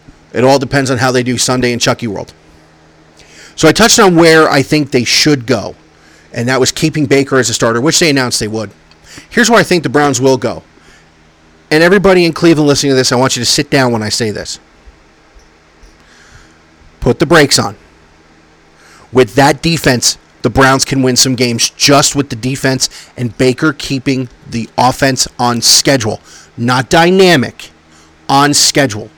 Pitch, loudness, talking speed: 125 Hz, -10 LUFS, 180 wpm